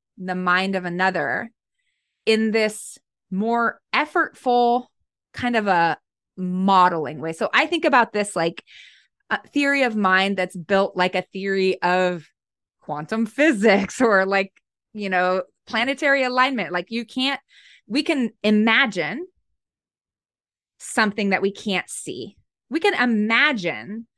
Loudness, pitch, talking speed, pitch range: -21 LUFS, 215 Hz, 125 wpm, 185-255 Hz